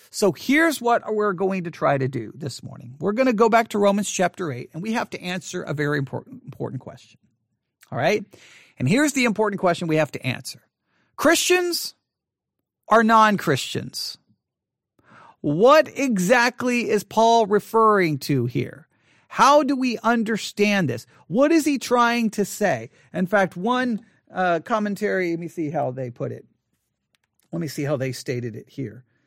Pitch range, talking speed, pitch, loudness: 150-230 Hz, 170 wpm, 200 Hz, -21 LUFS